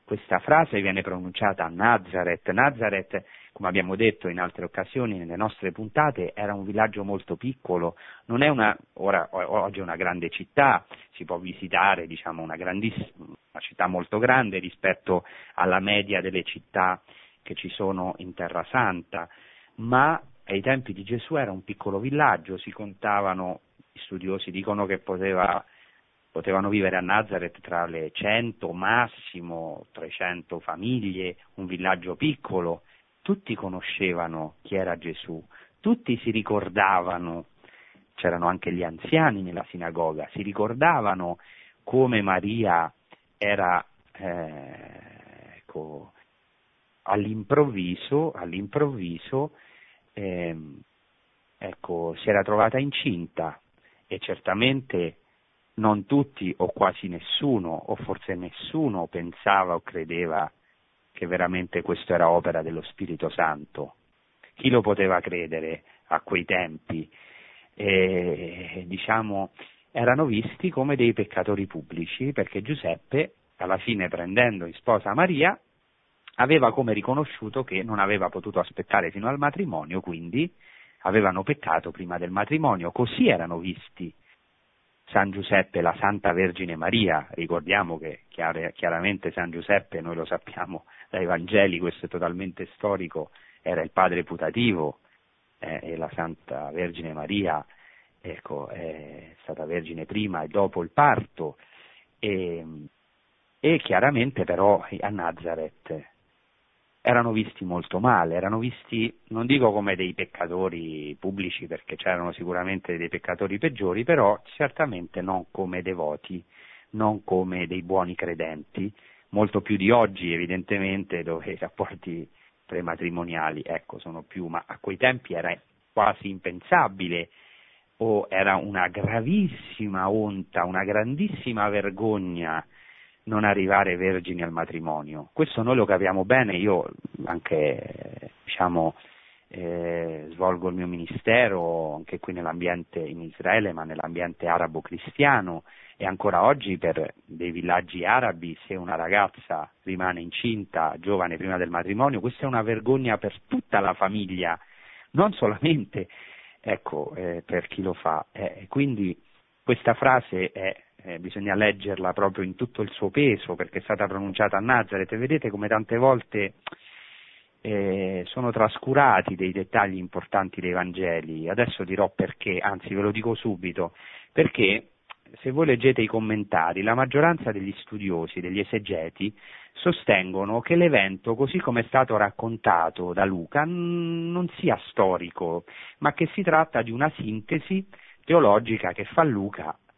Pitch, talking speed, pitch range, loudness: 95 Hz, 130 wpm, 90-110 Hz, -26 LUFS